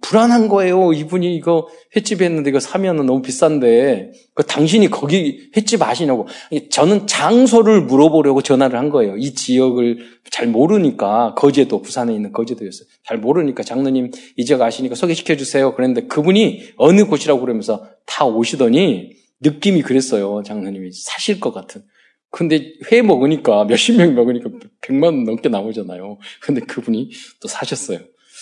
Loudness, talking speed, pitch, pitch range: -15 LUFS, 365 characters per minute, 155 Hz, 130-210 Hz